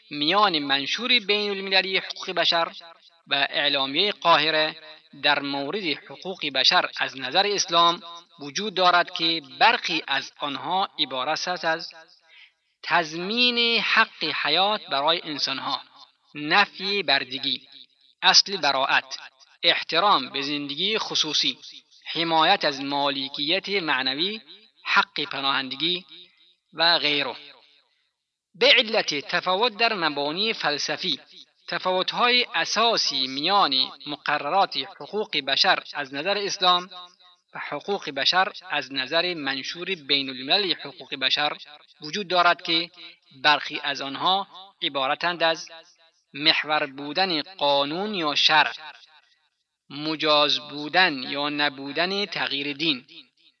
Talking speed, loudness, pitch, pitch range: 100 wpm, -22 LUFS, 165 Hz, 145-190 Hz